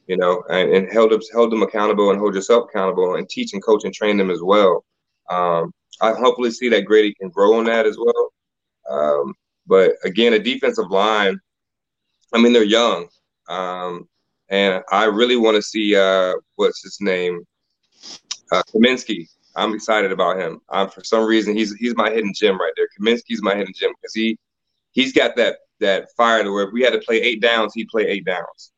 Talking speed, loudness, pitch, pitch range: 200 wpm, -18 LUFS, 110 Hz, 100-130 Hz